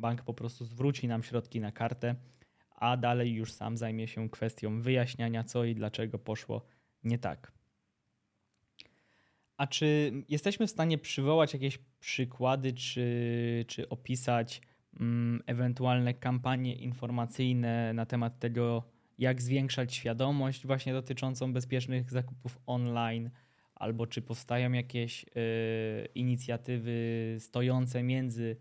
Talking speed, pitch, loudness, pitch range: 115 wpm, 120 Hz, -34 LUFS, 115-130 Hz